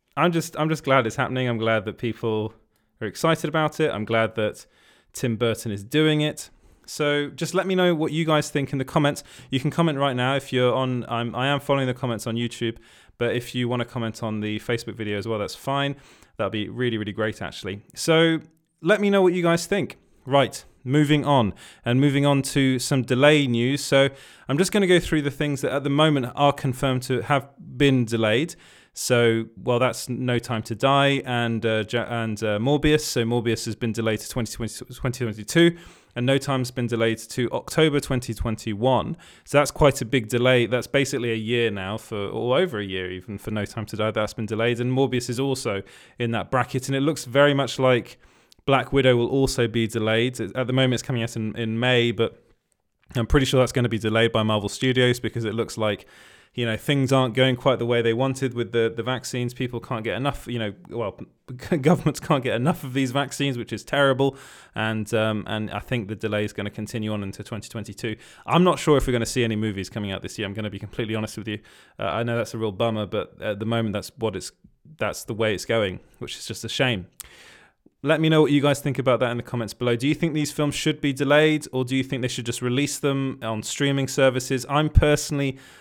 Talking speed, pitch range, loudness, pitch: 230 wpm, 115-140 Hz, -23 LUFS, 125 Hz